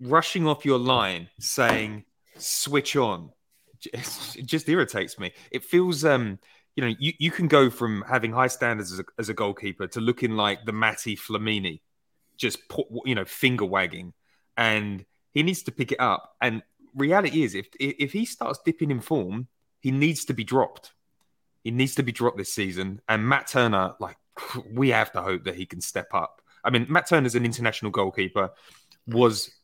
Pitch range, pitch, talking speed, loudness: 105-140 Hz, 120 Hz, 190 wpm, -25 LUFS